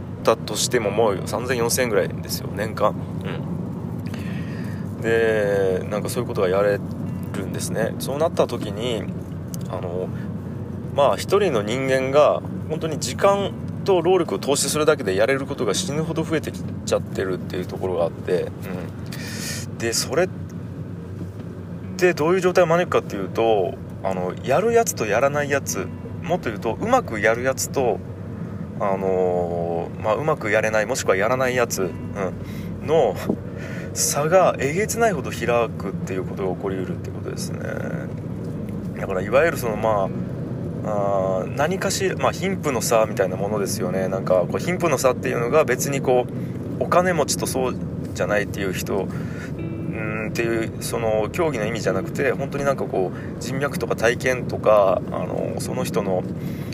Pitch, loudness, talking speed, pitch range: 115 Hz, -22 LUFS, 325 characters per minute, 95-140 Hz